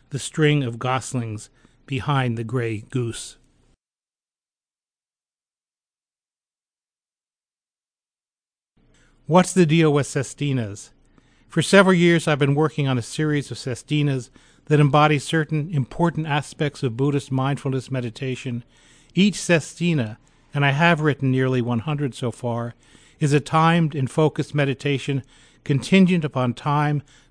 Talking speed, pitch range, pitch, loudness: 115 wpm, 125-150 Hz, 140 Hz, -21 LUFS